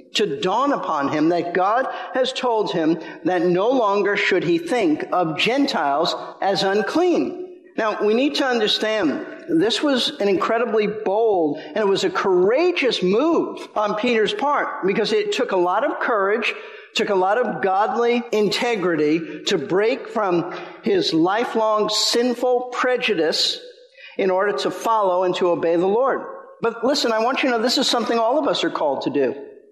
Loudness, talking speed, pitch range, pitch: -20 LUFS, 170 wpm, 210-330 Hz, 245 Hz